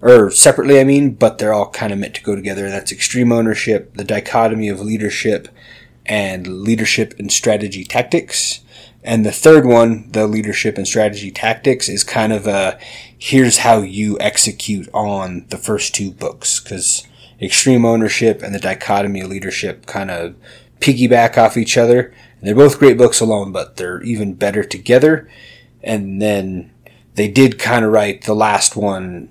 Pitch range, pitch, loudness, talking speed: 100-120 Hz, 110 Hz, -14 LUFS, 170 wpm